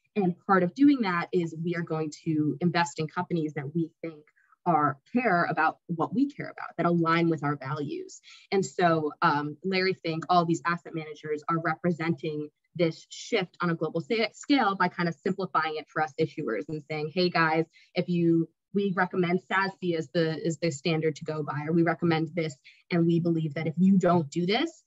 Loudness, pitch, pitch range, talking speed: -28 LUFS, 170 Hz, 160-180 Hz, 200 wpm